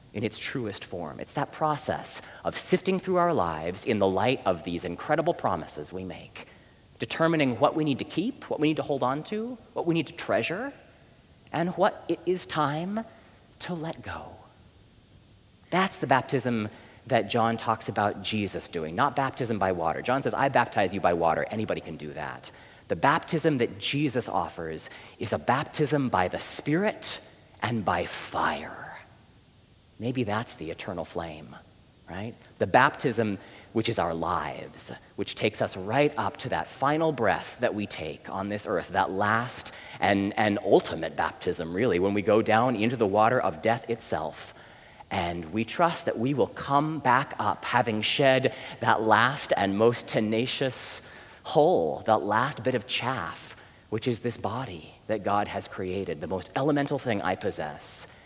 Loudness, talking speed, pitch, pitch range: -27 LUFS, 170 wpm, 115 Hz, 100-140 Hz